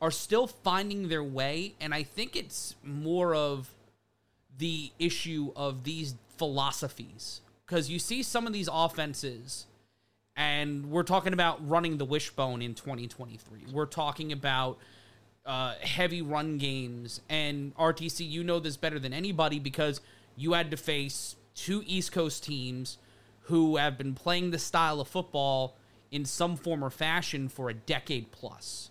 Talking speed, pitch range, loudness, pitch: 155 wpm, 125-165 Hz, -32 LUFS, 145 Hz